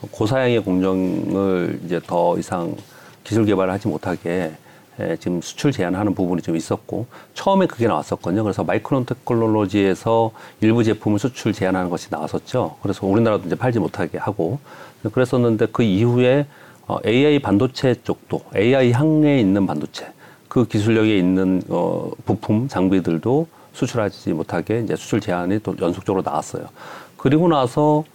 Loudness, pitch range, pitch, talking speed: -20 LUFS, 95-125 Hz, 110 Hz, 350 characters per minute